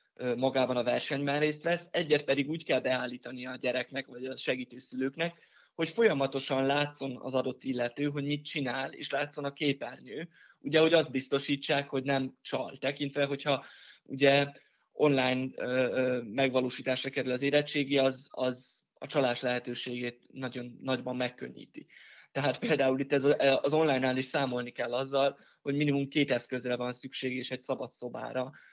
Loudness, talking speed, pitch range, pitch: -31 LUFS, 145 wpm, 130-140 Hz, 135 Hz